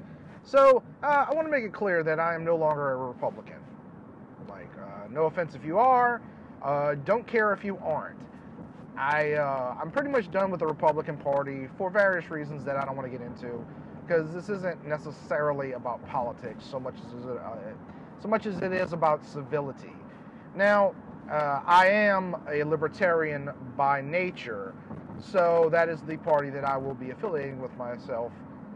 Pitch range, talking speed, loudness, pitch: 145-205 Hz, 180 wpm, -27 LUFS, 165 Hz